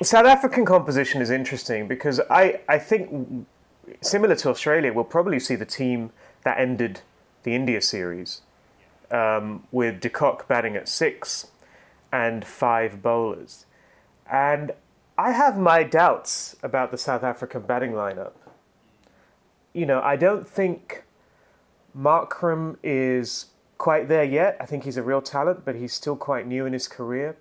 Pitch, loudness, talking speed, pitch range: 135 Hz, -23 LUFS, 145 wpm, 120-160 Hz